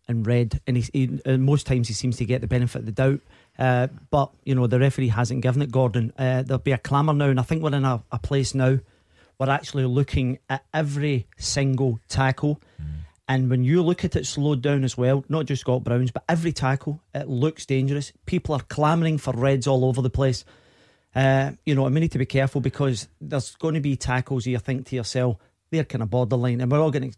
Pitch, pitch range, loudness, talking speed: 130 Hz, 125-140 Hz, -23 LUFS, 235 wpm